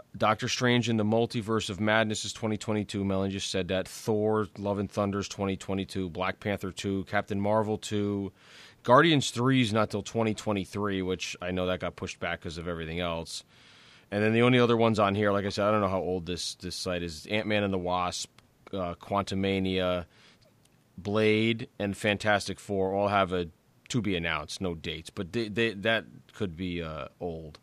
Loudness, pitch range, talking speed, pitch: -29 LUFS, 95-110 Hz, 190 wpm, 100 Hz